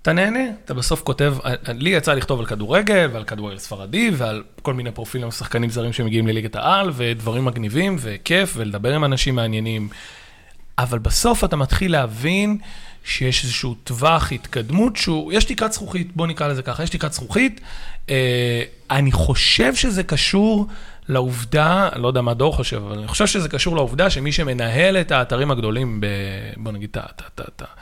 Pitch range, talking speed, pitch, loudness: 115-175 Hz, 165 wpm, 130 Hz, -20 LUFS